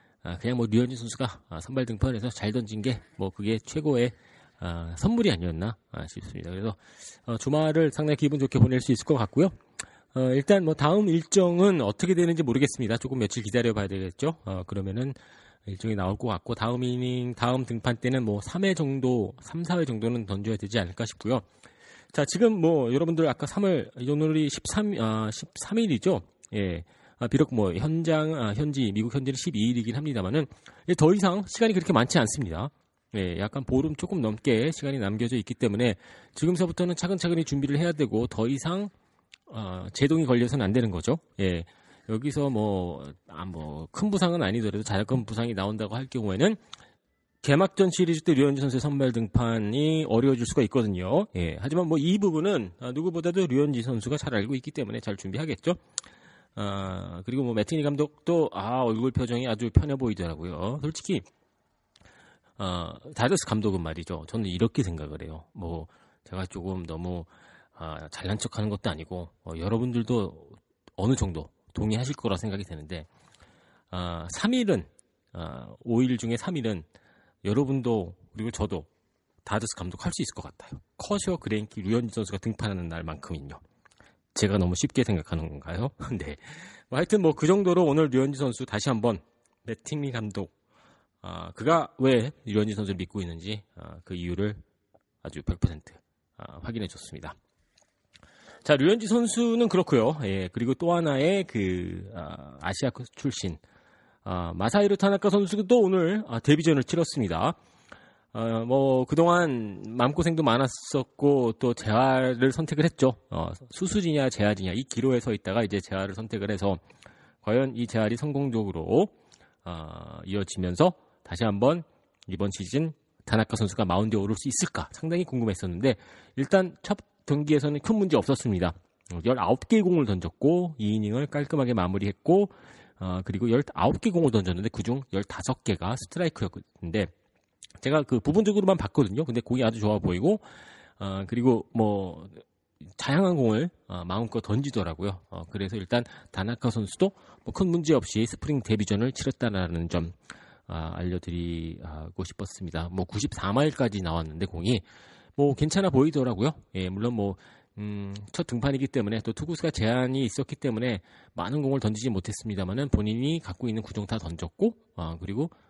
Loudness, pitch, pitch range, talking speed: -27 LUFS, 115 Hz, 100-145 Hz, 335 characters per minute